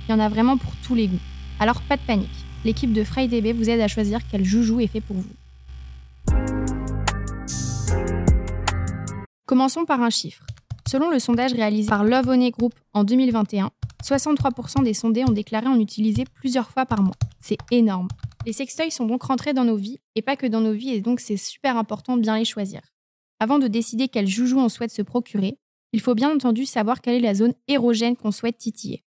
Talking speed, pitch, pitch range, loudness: 200 wpm, 225 Hz, 195-245 Hz, -22 LUFS